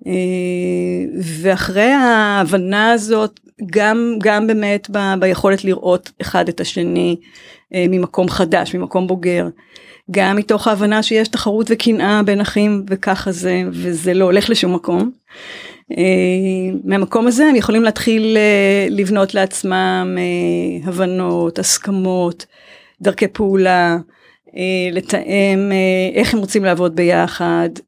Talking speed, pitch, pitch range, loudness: 105 wpm, 195 Hz, 180-210 Hz, -15 LUFS